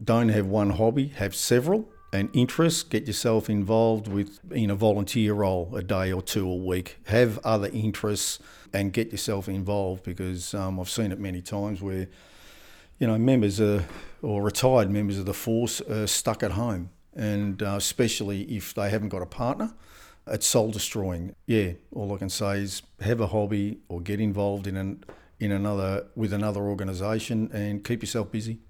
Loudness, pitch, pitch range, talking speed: -27 LUFS, 105 Hz, 100-110 Hz, 180 wpm